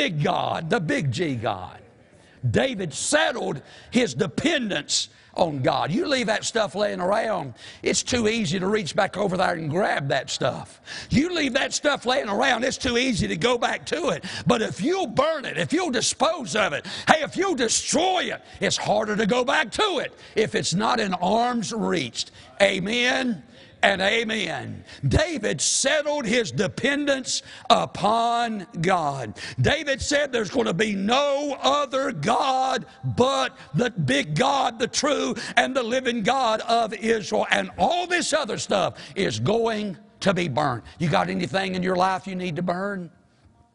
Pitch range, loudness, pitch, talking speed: 190-260 Hz, -23 LUFS, 225 Hz, 165 wpm